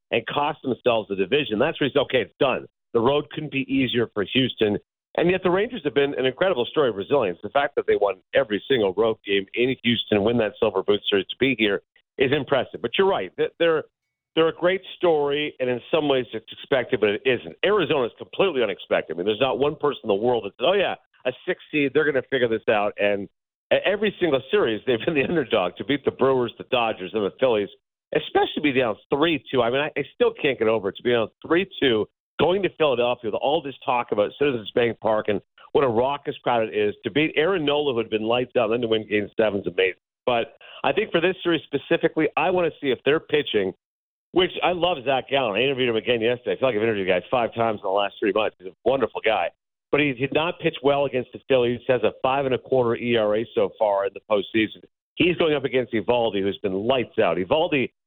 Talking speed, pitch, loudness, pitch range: 245 wpm, 135 Hz, -23 LUFS, 115-170 Hz